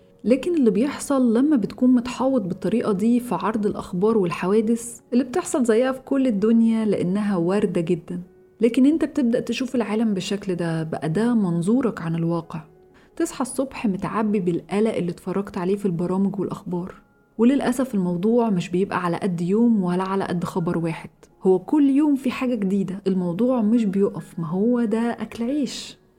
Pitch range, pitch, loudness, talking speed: 185-240 Hz, 215 Hz, -22 LUFS, 160 wpm